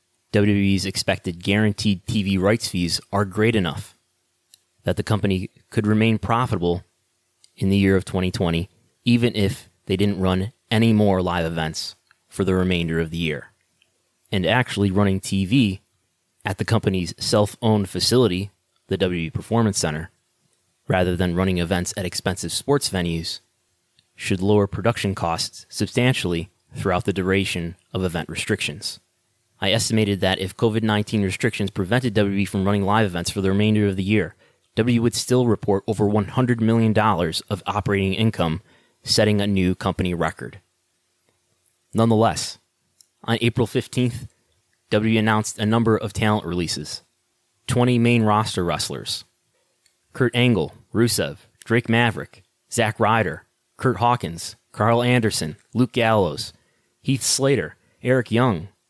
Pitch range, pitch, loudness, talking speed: 90-115 Hz, 105 Hz, -21 LUFS, 135 wpm